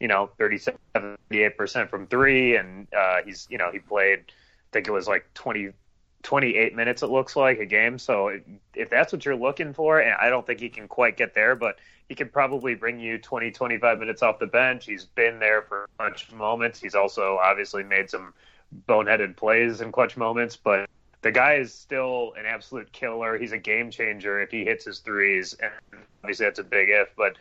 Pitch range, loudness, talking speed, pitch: 105-130 Hz, -23 LUFS, 210 wpm, 115 Hz